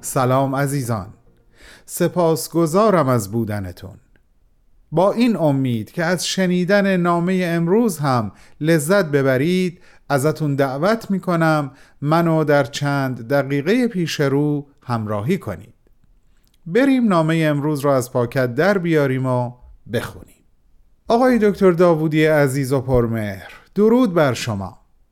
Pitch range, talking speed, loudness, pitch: 130-180 Hz, 110 wpm, -18 LUFS, 150 Hz